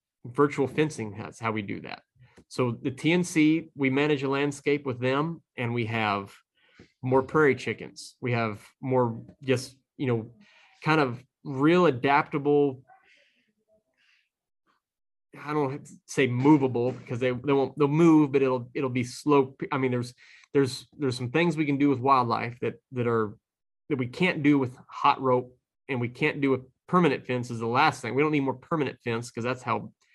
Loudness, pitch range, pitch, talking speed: -26 LUFS, 125-150 Hz, 135 Hz, 175 wpm